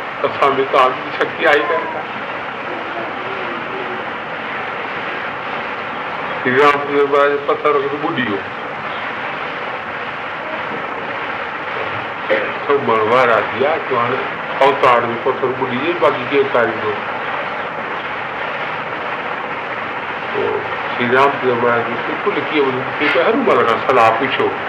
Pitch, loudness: 145 Hz, -17 LUFS